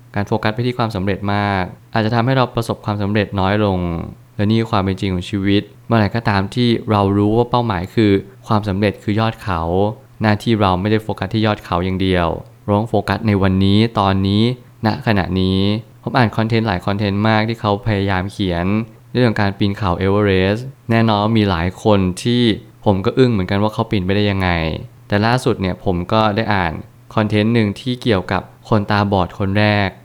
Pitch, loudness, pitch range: 105 Hz, -17 LUFS, 100-115 Hz